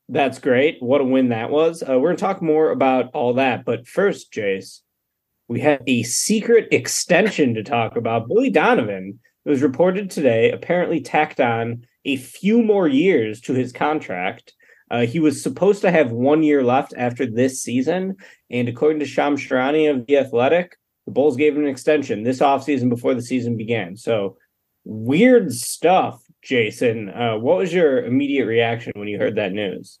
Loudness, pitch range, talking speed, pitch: -19 LUFS, 120-155 Hz, 180 wpm, 135 Hz